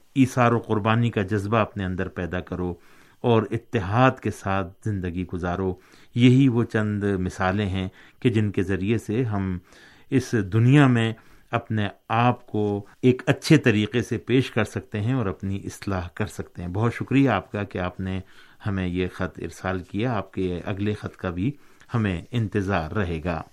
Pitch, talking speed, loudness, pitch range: 105 Hz, 175 wpm, -24 LUFS, 95-120 Hz